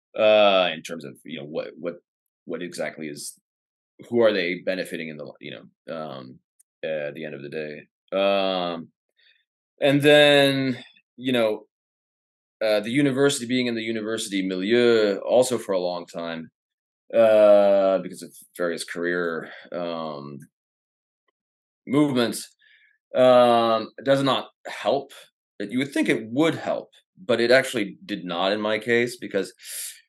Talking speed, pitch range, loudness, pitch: 140 wpm, 85-125 Hz, -22 LUFS, 105 Hz